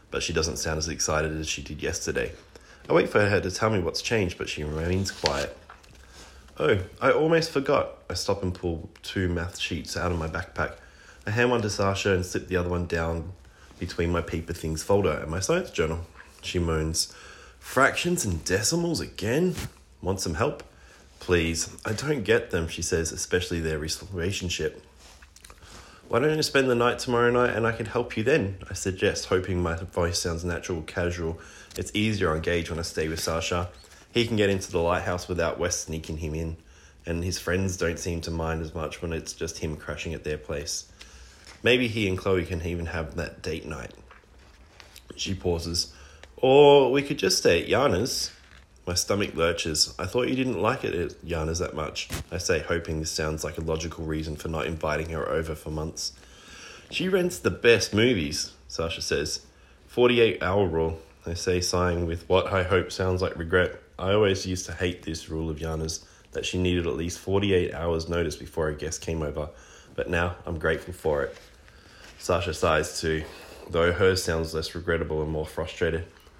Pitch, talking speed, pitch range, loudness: 85 Hz, 190 wpm, 80-95 Hz, -26 LUFS